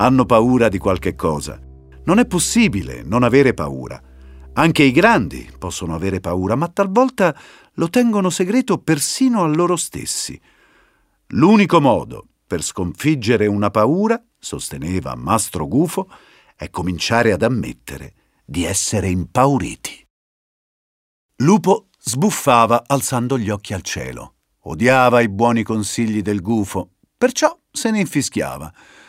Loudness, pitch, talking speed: -17 LUFS, 120 Hz, 120 wpm